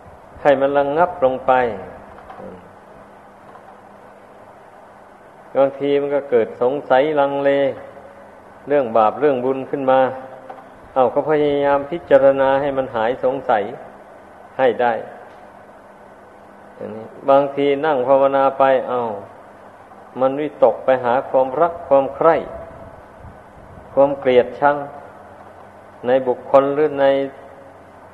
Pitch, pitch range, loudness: 140 Hz, 130-145 Hz, -17 LUFS